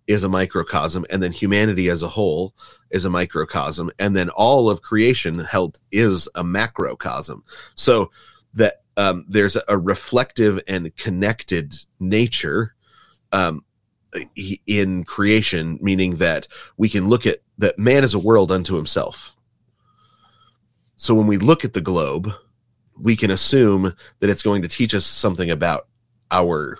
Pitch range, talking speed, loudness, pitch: 90-110 Hz, 145 wpm, -19 LUFS, 100 Hz